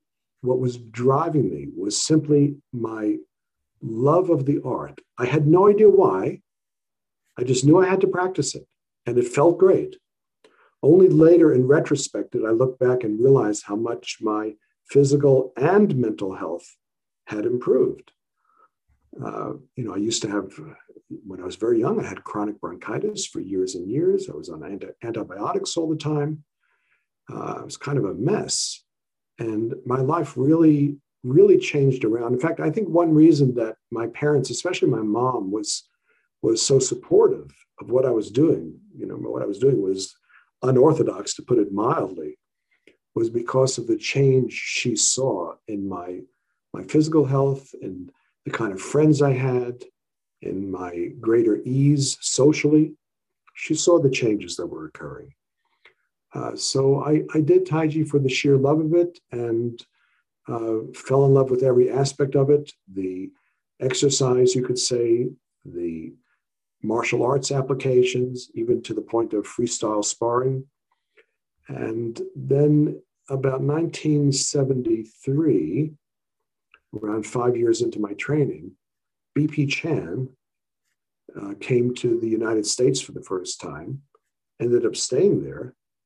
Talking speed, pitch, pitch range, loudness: 150 wpm, 145 Hz, 125-185 Hz, -21 LUFS